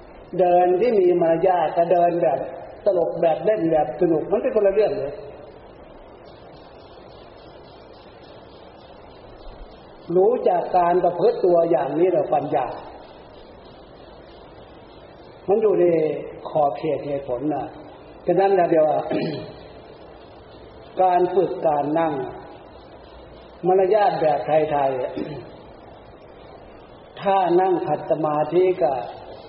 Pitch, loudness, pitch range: 175 Hz, -20 LUFS, 155-195 Hz